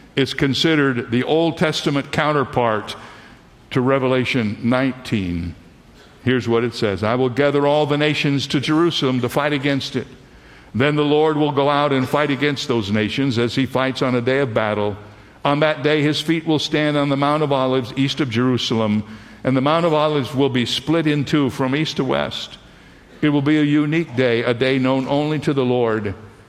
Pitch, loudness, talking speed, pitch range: 135 Hz, -19 LUFS, 195 wpm, 120-150 Hz